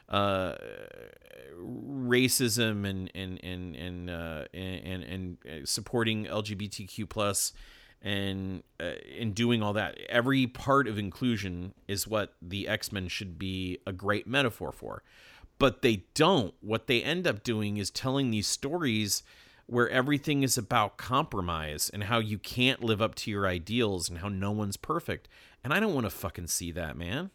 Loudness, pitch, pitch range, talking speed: -30 LUFS, 105 Hz, 95-120 Hz, 160 wpm